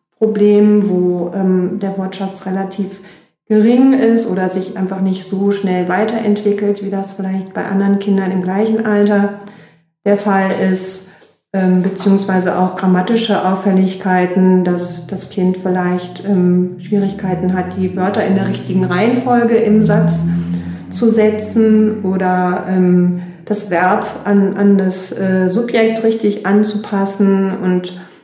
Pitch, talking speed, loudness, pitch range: 195 Hz, 130 wpm, -14 LUFS, 185-205 Hz